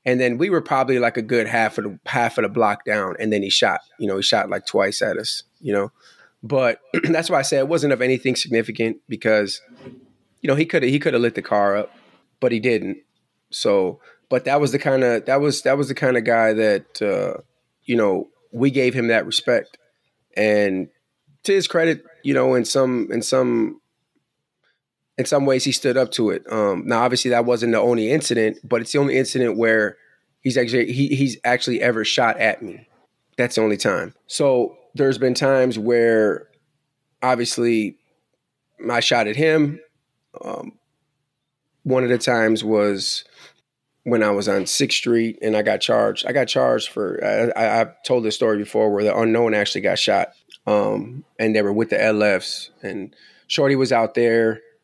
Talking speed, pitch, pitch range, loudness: 195 wpm, 120 Hz, 110-135 Hz, -20 LUFS